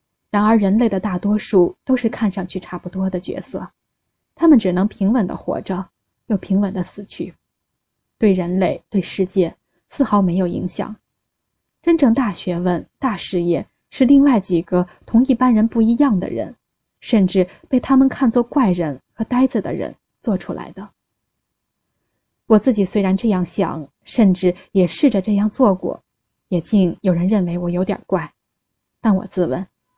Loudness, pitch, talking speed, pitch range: -18 LUFS, 195 Hz, 235 characters per minute, 180-225 Hz